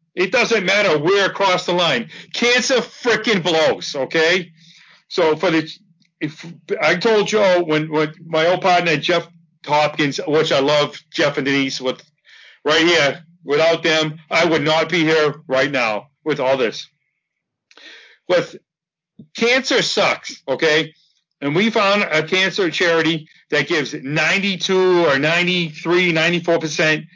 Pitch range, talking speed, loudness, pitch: 155-185 Hz, 140 wpm, -17 LUFS, 165 Hz